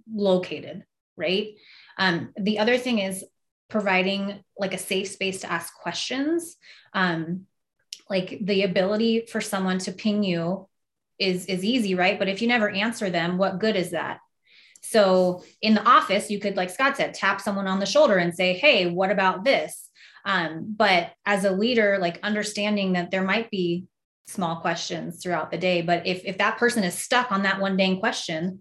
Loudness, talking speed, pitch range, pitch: -24 LUFS, 180 wpm, 185-215 Hz, 195 Hz